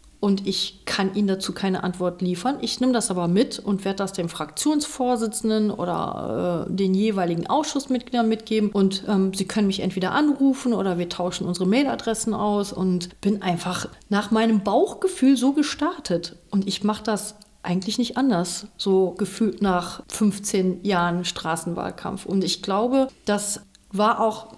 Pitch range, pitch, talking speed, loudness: 185-225 Hz, 200 Hz, 155 wpm, -23 LUFS